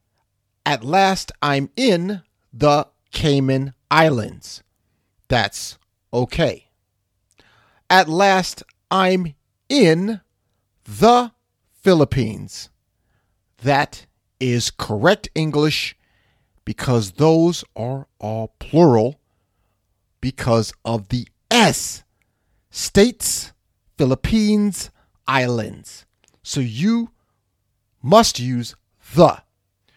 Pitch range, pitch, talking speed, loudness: 105-155 Hz, 120 Hz, 70 wpm, -18 LUFS